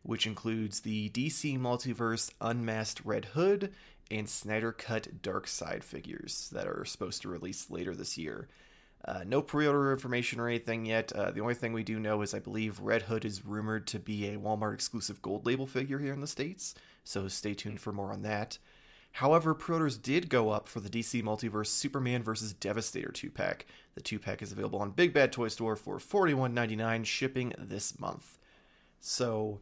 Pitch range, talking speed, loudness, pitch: 105-125 Hz, 195 wpm, -34 LUFS, 115 Hz